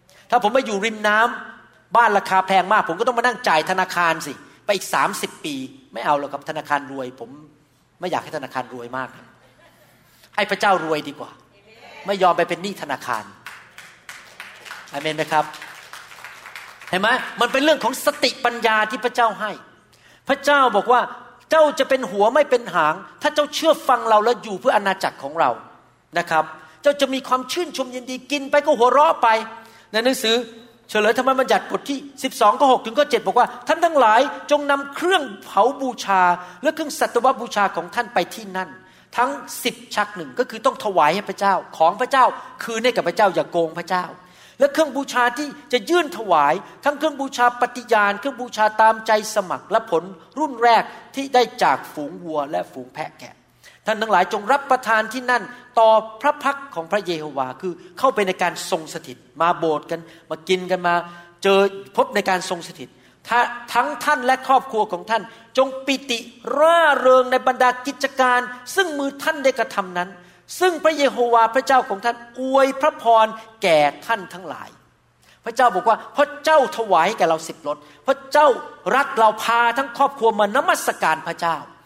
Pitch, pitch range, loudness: 225 Hz, 180-265 Hz, -20 LUFS